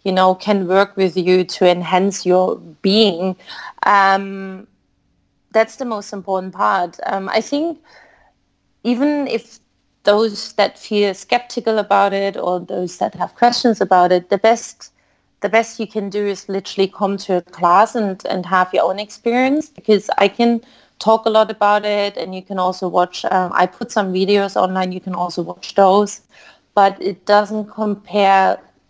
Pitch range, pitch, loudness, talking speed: 185-220 Hz, 200 Hz, -17 LUFS, 170 wpm